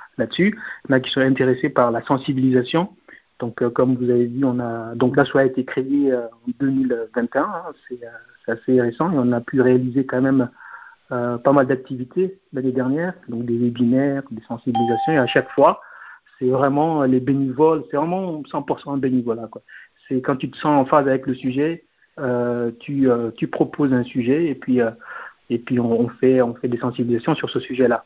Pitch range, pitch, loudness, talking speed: 125-145 Hz, 130 Hz, -20 LUFS, 205 wpm